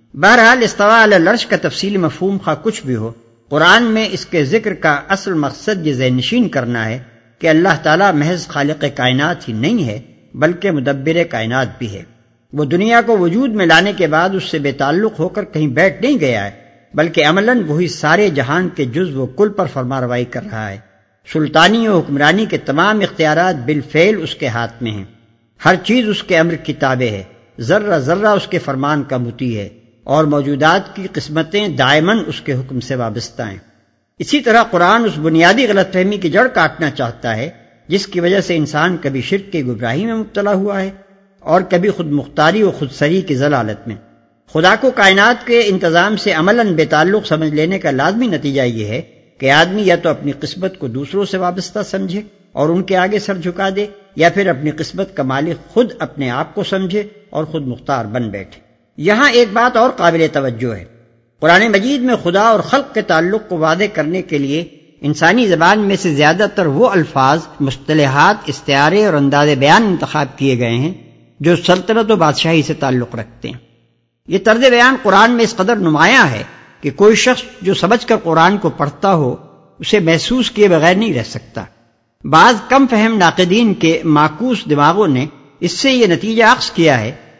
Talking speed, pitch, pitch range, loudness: 190 wpm, 165 Hz, 140-200 Hz, -13 LUFS